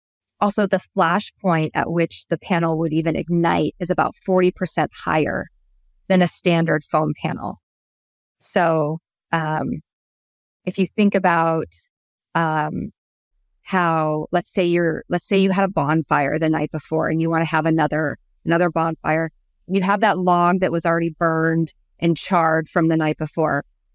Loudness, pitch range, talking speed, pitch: -20 LUFS, 155-175 Hz, 160 wpm, 165 Hz